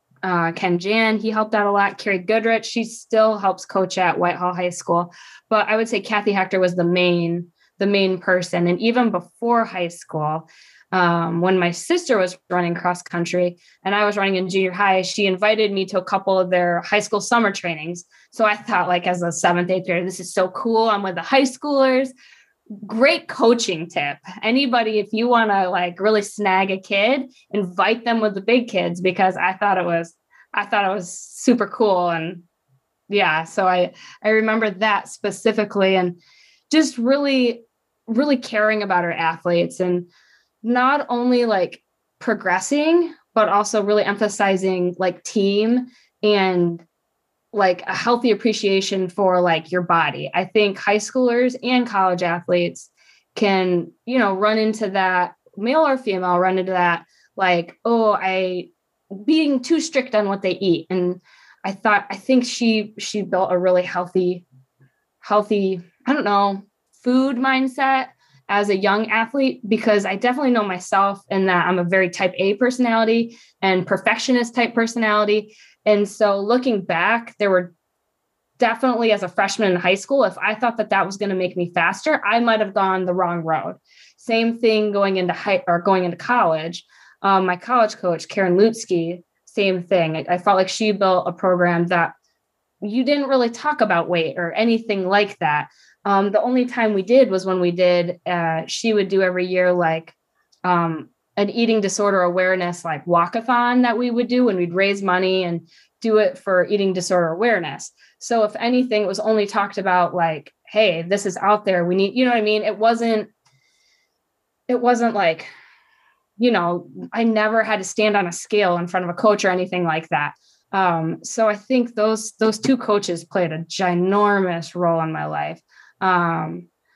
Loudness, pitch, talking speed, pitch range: -19 LUFS, 200 Hz, 180 wpm, 180-225 Hz